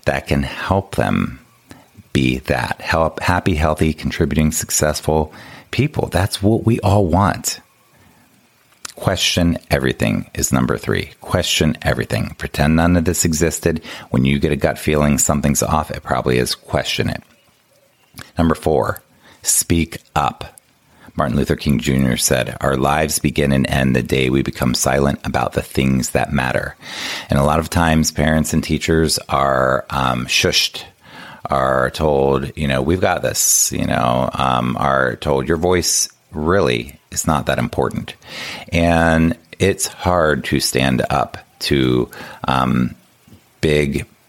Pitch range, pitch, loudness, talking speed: 65-85 Hz, 75 Hz, -17 LUFS, 140 wpm